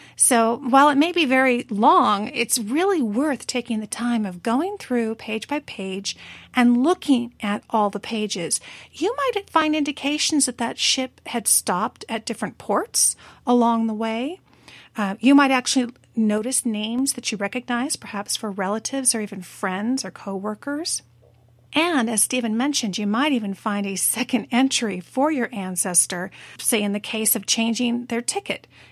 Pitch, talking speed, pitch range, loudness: 235 Hz, 165 wpm, 210-265 Hz, -22 LUFS